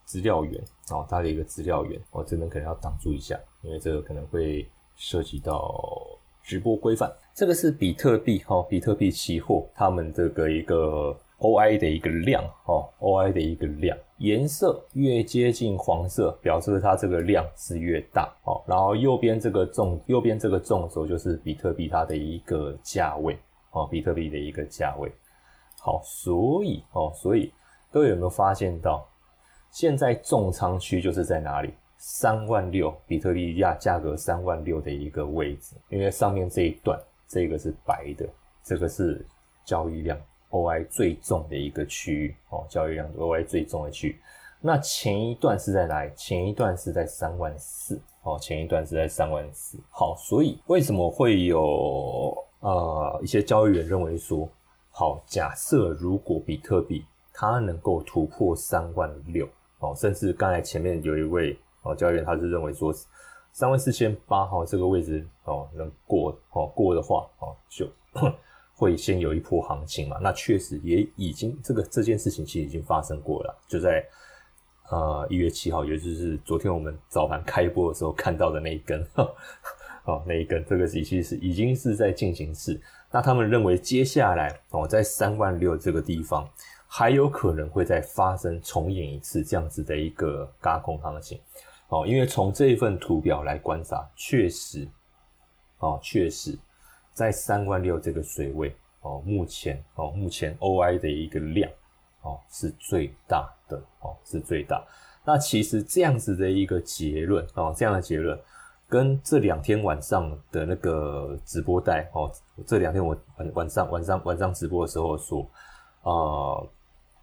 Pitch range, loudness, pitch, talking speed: 80-105 Hz, -26 LUFS, 90 Hz, 255 characters per minute